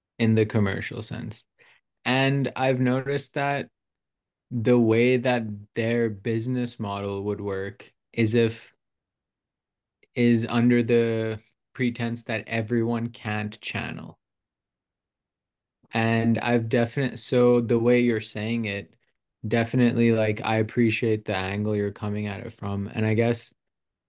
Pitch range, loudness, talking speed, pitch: 110-120 Hz, -25 LUFS, 120 wpm, 115 Hz